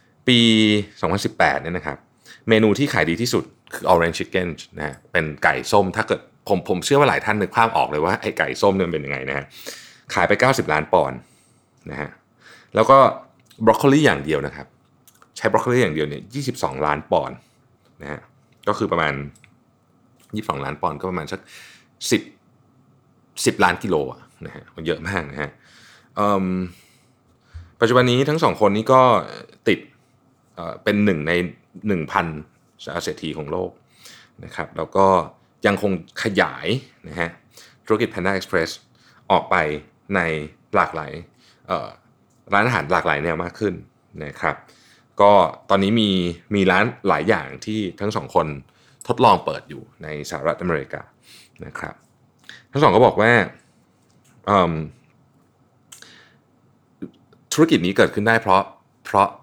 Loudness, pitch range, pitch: -20 LUFS, 80-115 Hz, 100 Hz